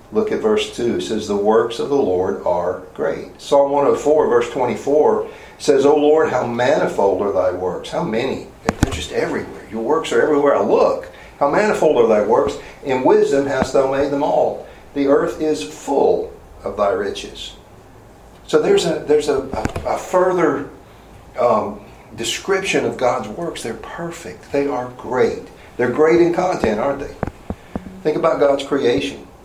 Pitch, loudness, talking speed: 170 Hz, -18 LUFS, 170 wpm